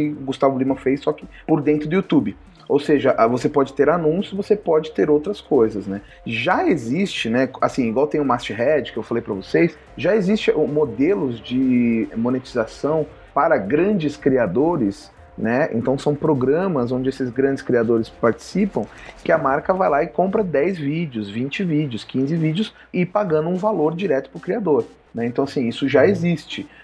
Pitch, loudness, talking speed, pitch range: 150 Hz, -20 LUFS, 175 wpm, 130-175 Hz